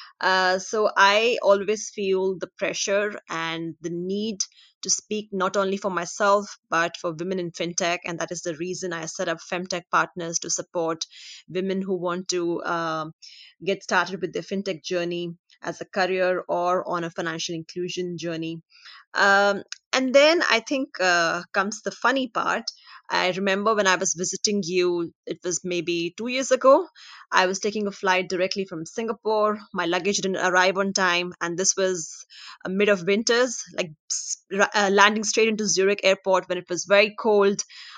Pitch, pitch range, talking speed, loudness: 185 Hz, 175-200 Hz, 170 wpm, -23 LUFS